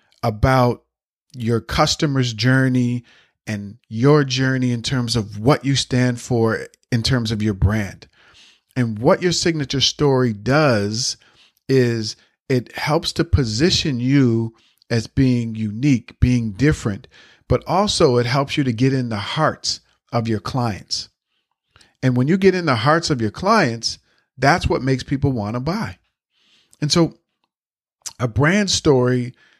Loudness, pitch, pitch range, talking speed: -19 LUFS, 125 Hz, 115-140 Hz, 140 wpm